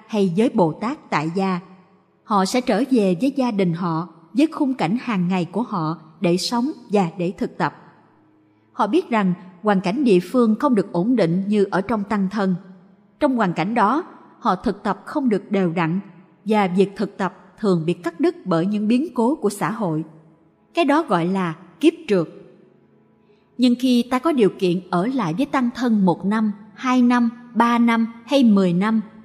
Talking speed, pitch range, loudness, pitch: 195 wpm, 180-240 Hz, -20 LUFS, 200 Hz